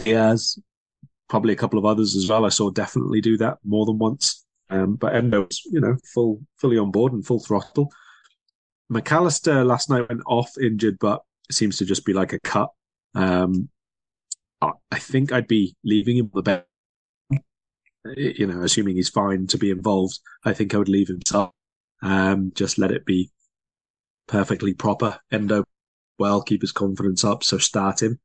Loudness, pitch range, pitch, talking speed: -22 LUFS, 100-120 Hz, 105 Hz, 180 wpm